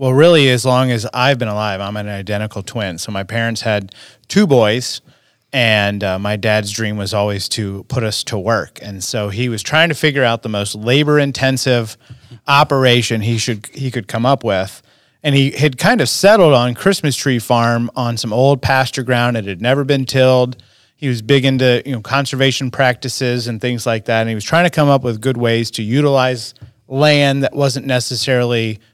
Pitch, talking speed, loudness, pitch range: 125 Hz, 200 wpm, -15 LUFS, 110-135 Hz